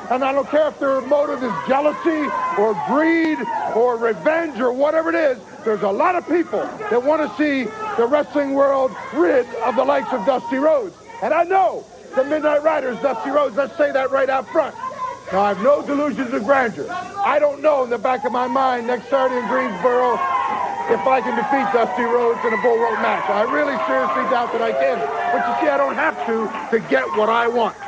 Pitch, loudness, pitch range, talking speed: 275 Hz, -19 LUFS, 245-305 Hz, 215 wpm